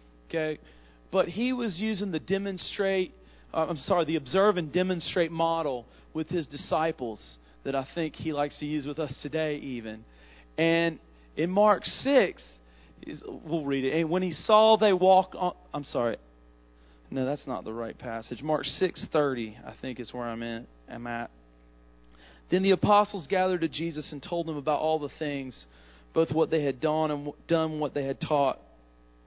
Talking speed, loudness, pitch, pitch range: 175 wpm, -28 LUFS, 150 Hz, 115-170 Hz